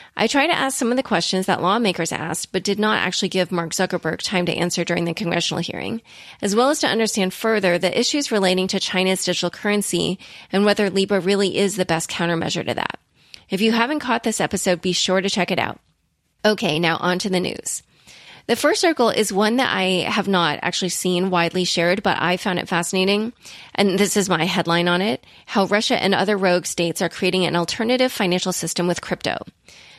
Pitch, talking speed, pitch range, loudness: 185 Hz, 210 wpm, 175-210 Hz, -20 LUFS